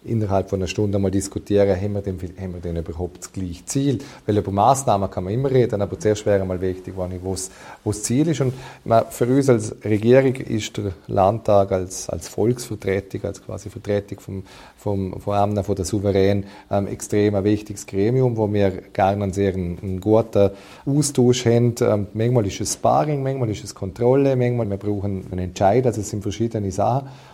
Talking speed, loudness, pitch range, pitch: 190 wpm, -21 LUFS, 95-115 Hz, 100 Hz